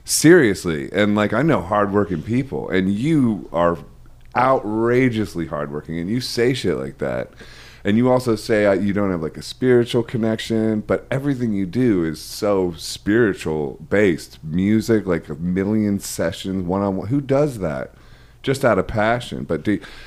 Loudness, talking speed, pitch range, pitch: -20 LUFS, 160 wpm, 90-115 Hz, 105 Hz